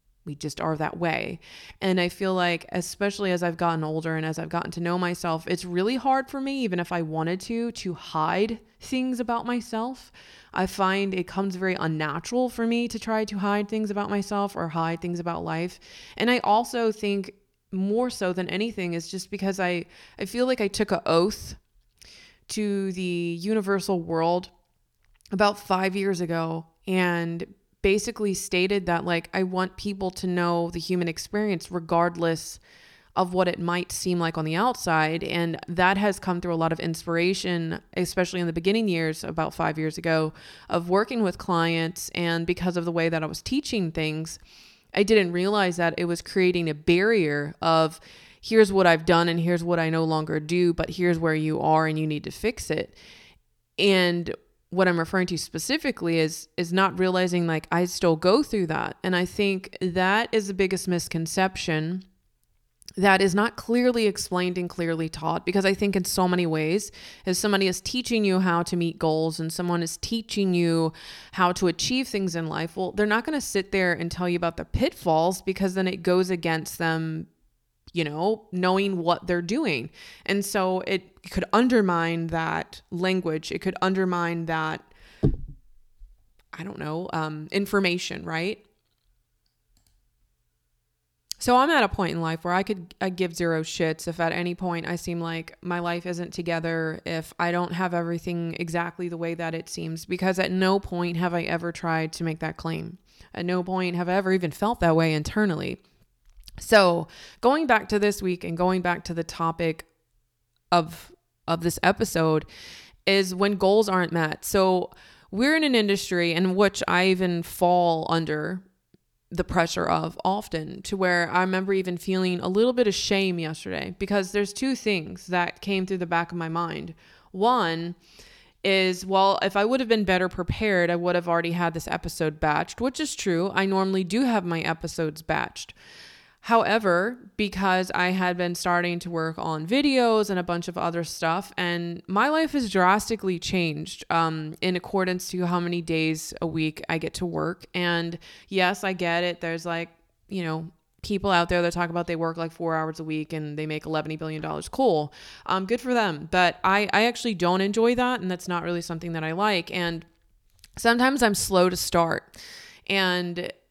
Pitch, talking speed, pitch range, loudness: 180 Hz, 185 wpm, 165-195 Hz, -25 LUFS